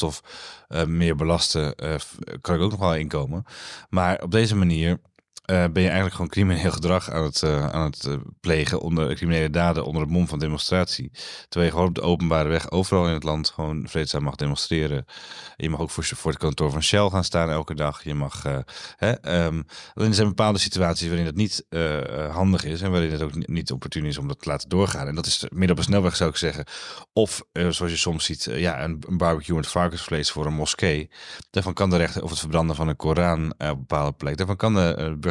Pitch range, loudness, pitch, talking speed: 75-90 Hz, -24 LUFS, 80 Hz, 235 wpm